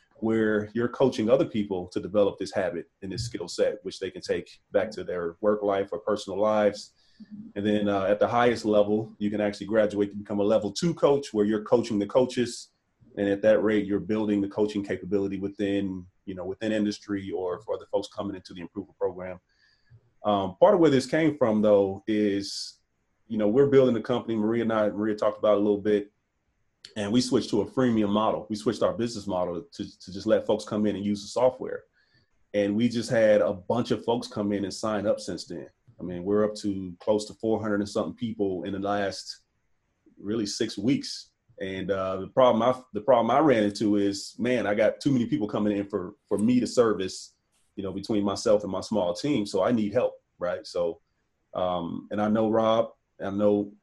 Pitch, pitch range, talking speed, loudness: 105 Hz, 100-120 Hz, 215 wpm, -26 LUFS